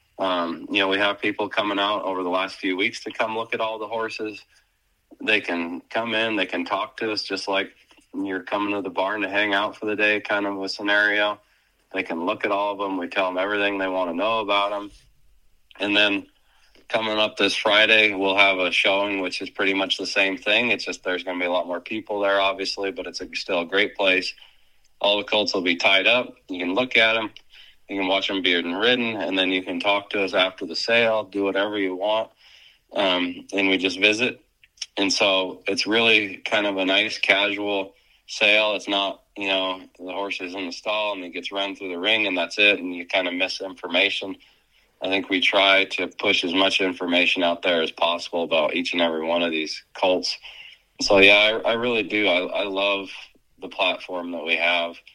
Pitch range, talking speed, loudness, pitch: 95-105 Hz, 225 wpm, -21 LUFS, 100 Hz